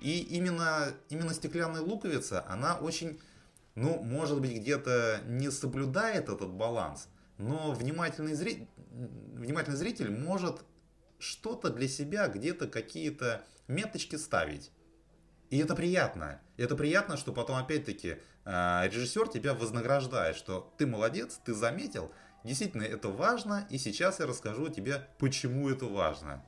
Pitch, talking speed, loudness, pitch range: 140 Hz, 125 wpm, -34 LUFS, 115-160 Hz